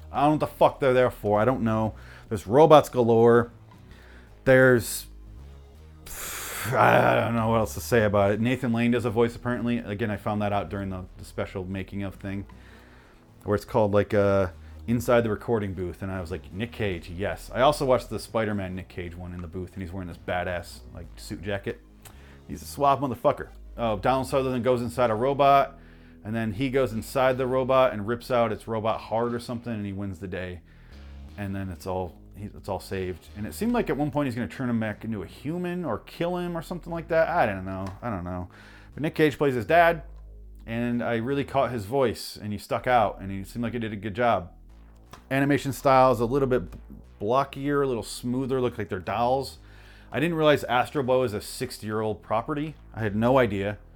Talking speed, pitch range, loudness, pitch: 220 wpm, 95-125 Hz, -25 LUFS, 110 Hz